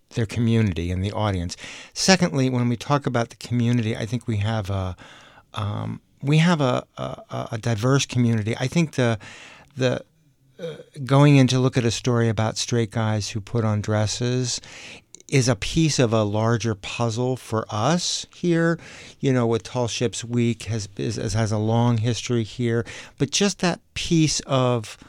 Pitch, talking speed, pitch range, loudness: 120 Hz, 170 wpm, 110-130 Hz, -23 LUFS